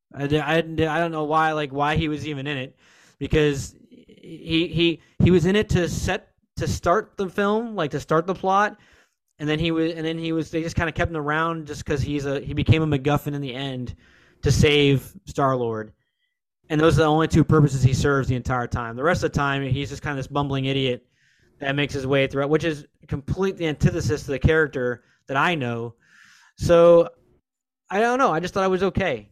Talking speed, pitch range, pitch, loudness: 210 wpm, 135-165 Hz, 150 Hz, -22 LUFS